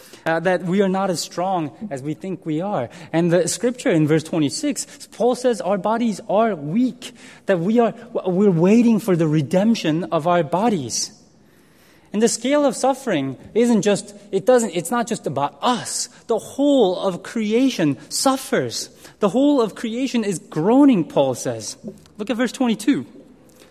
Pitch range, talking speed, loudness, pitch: 170-240 Hz, 165 wpm, -20 LUFS, 200 Hz